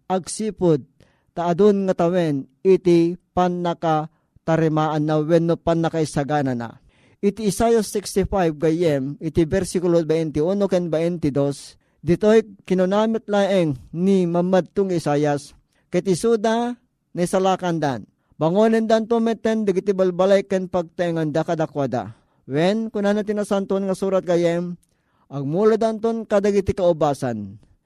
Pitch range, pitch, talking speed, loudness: 155-200 Hz, 175 Hz, 115 wpm, -21 LUFS